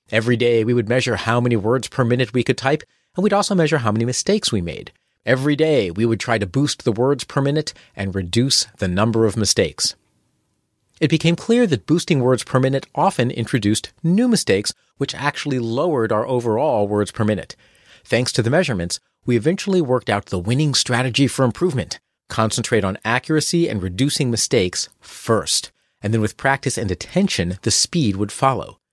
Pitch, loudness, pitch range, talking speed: 125 Hz, -19 LUFS, 110-145 Hz, 185 wpm